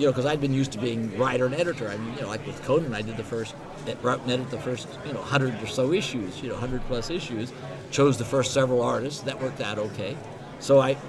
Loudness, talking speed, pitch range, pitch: -27 LUFS, 265 wpm, 120-135 Hz, 130 Hz